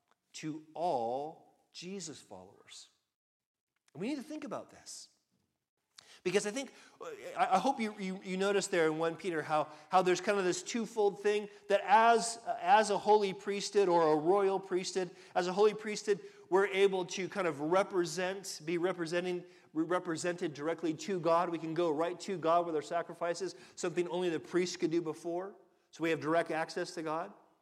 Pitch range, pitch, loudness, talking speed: 170-200 Hz, 180 Hz, -33 LUFS, 175 wpm